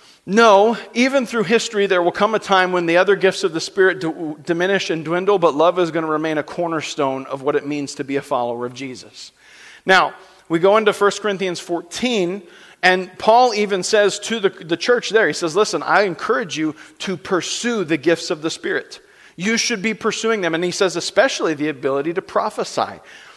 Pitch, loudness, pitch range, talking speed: 185 Hz, -18 LUFS, 165-215 Hz, 205 wpm